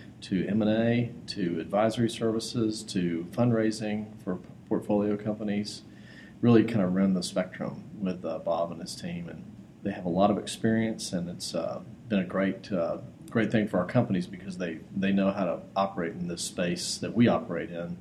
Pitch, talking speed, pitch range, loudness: 105 Hz, 185 wpm, 90-110 Hz, -29 LUFS